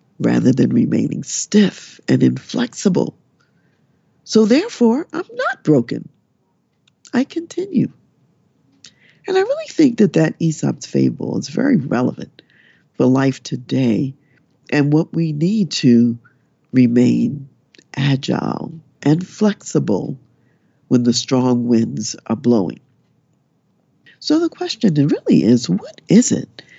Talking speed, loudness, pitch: 110 wpm, -17 LUFS, 145 Hz